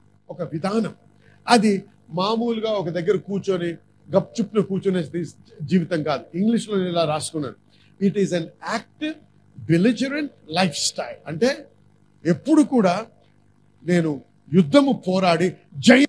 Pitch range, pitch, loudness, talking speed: 165-215 Hz, 185 Hz, -22 LUFS, 110 wpm